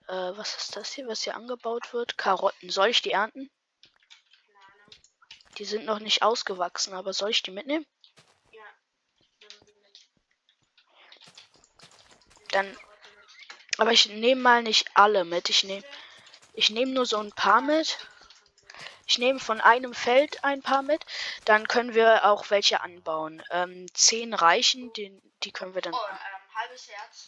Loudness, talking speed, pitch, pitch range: -24 LUFS, 145 wpm, 220 Hz, 195-250 Hz